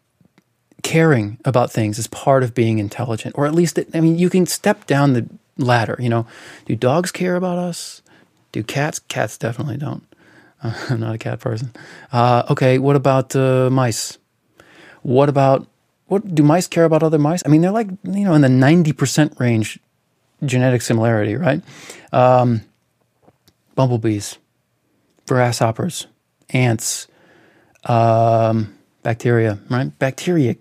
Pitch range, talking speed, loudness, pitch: 115-160 Hz, 145 wpm, -17 LUFS, 130 Hz